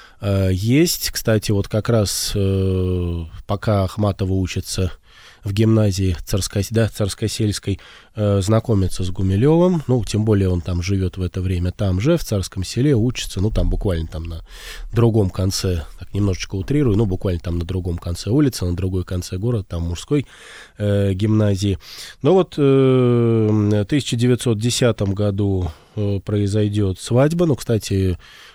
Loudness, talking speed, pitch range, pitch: -19 LUFS, 145 wpm, 95-115 Hz, 100 Hz